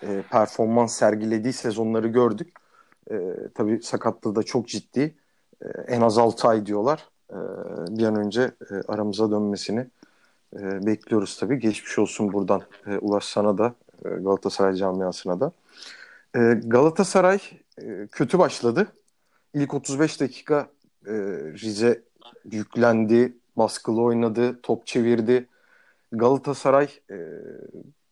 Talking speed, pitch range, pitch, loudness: 115 wpm, 105-125 Hz, 115 Hz, -23 LUFS